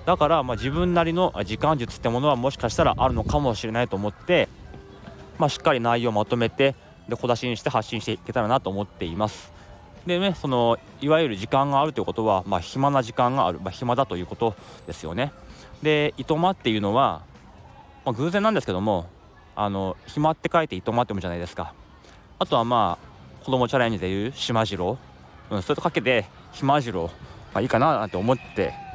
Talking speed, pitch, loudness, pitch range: 415 characters per minute, 120 Hz, -24 LUFS, 100-140 Hz